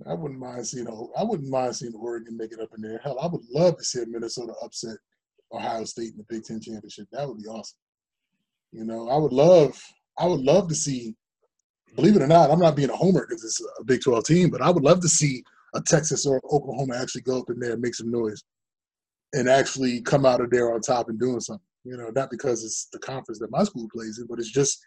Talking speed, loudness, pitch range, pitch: 260 wpm, -23 LUFS, 115-145 Hz, 125 Hz